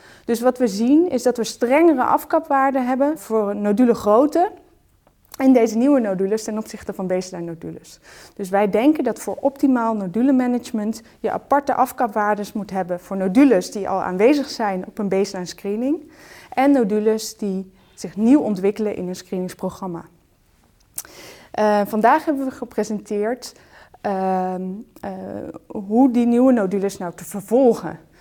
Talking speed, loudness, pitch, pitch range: 145 wpm, -20 LUFS, 220 Hz, 200-260 Hz